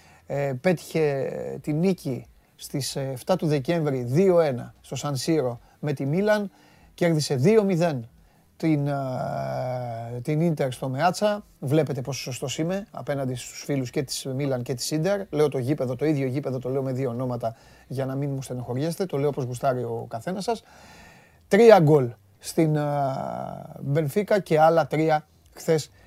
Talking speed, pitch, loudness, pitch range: 155 wpm, 145 Hz, -25 LUFS, 130-165 Hz